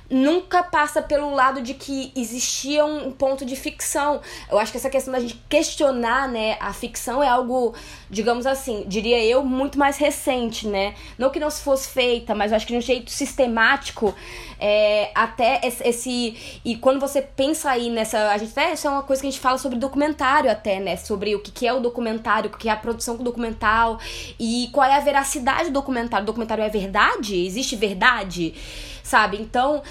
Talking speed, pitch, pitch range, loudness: 195 wpm, 250 Hz, 225-275 Hz, -21 LUFS